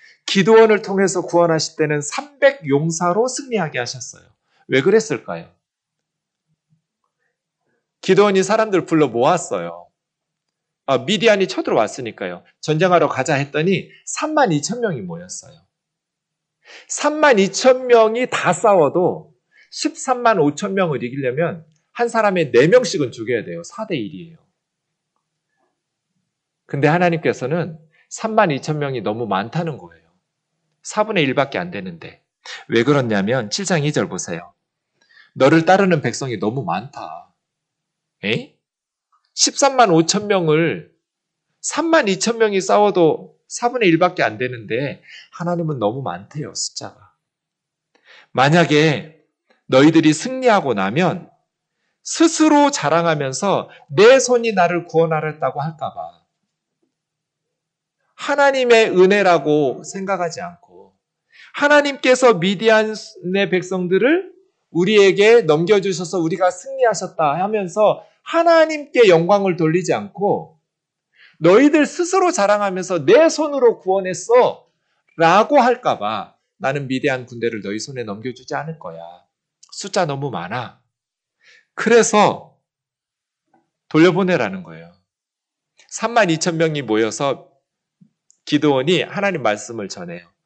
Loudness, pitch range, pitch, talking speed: -17 LUFS, 155-220 Hz, 175 Hz, 240 characters per minute